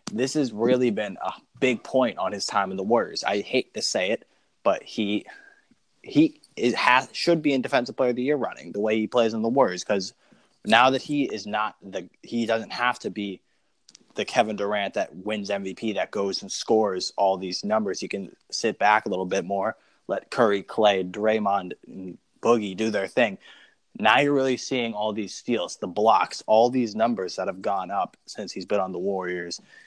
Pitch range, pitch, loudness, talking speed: 100-125 Hz, 110 Hz, -25 LUFS, 205 wpm